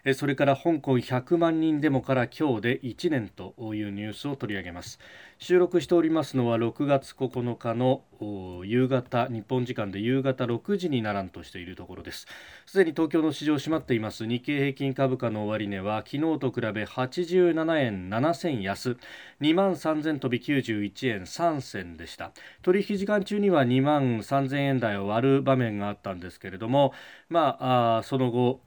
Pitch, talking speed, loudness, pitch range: 130 Hz, 290 characters per minute, -26 LUFS, 110-150 Hz